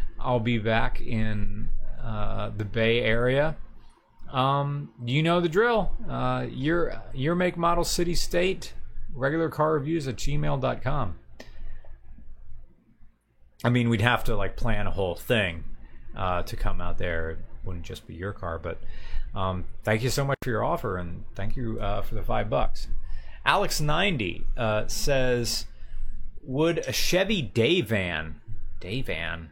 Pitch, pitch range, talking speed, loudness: 115 Hz, 100-140 Hz, 140 wpm, -27 LUFS